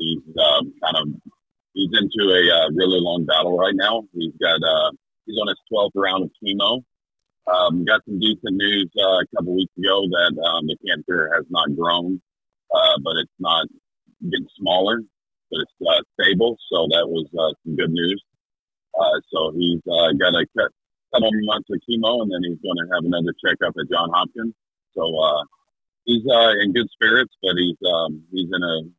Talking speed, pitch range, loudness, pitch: 190 wpm, 85-110 Hz, -19 LUFS, 95 Hz